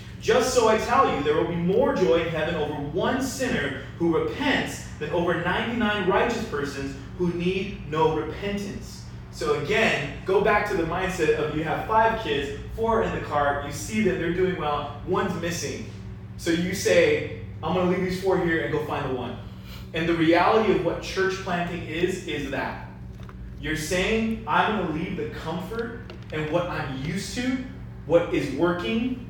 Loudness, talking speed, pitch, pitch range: -25 LUFS, 185 wpm, 170 Hz, 150-195 Hz